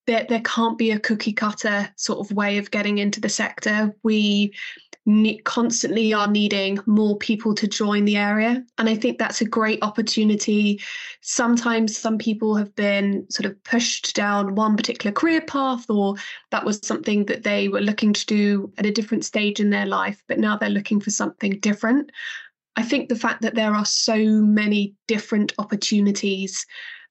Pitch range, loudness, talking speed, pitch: 205-230 Hz, -21 LUFS, 180 wpm, 215 Hz